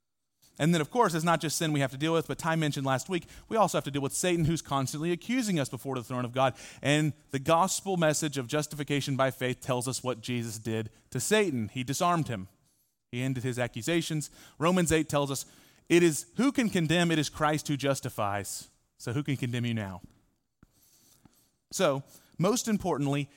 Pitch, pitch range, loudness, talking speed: 145 Hz, 130-165 Hz, -29 LUFS, 205 wpm